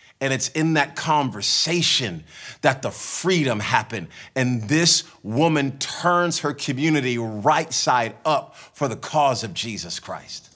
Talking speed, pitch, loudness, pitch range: 135 wpm, 145 Hz, -21 LUFS, 130-160 Hz